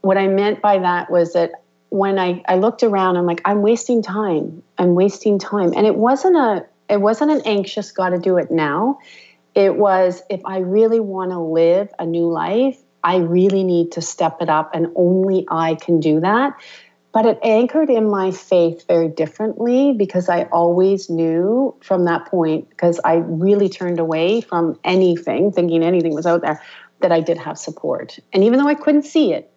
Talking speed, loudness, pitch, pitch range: 195 wpm, -17 LUFS, 185 Hz, 170-210 Hz